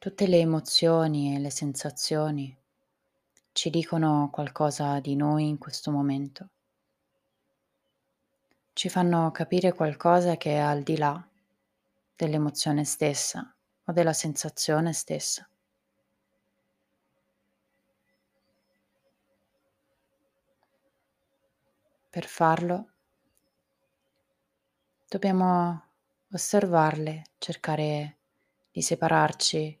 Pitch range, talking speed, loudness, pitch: 150-170 Hz, 70 wpm, -27 LUFS, 155 Hz